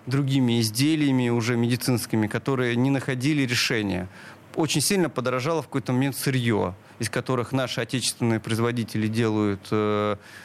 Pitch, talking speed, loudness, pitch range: 125 Hz, 125 wpm, -24 LUFS, 110-135 Hz